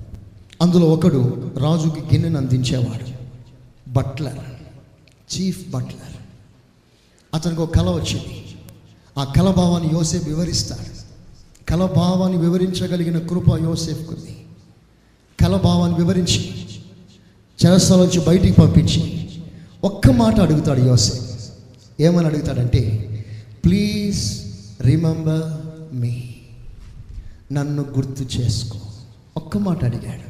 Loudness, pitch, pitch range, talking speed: -18 LUFS, 135 Hz, 115-165 Hz, 80 wpm